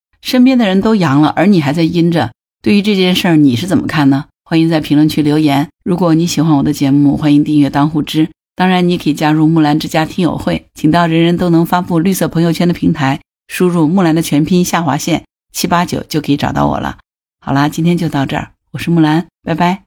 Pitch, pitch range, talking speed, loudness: 160 Hz, 145-175 Hz, 340 characters per minute, -12 LUFS